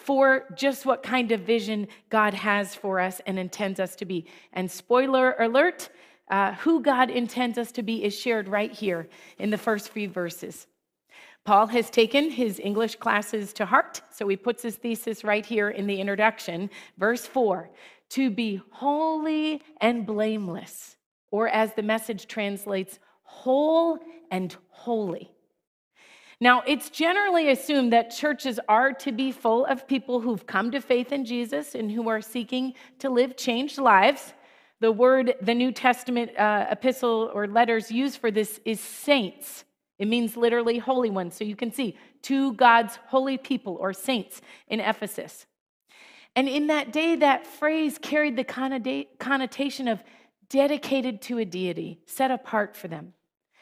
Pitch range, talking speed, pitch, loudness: 210-265 Hz, 160 wpm, 235 Hz, -25 LUFS